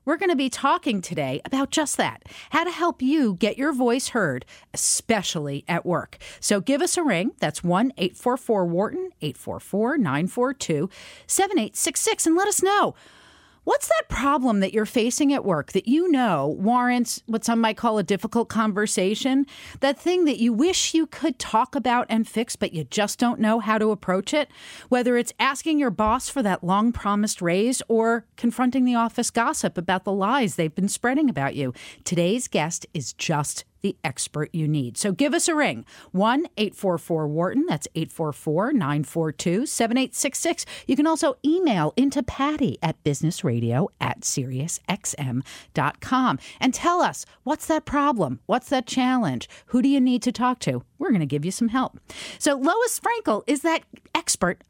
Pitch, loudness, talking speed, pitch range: 235 Hz, -23 LUFS, 170 wpm, 185-280 Hz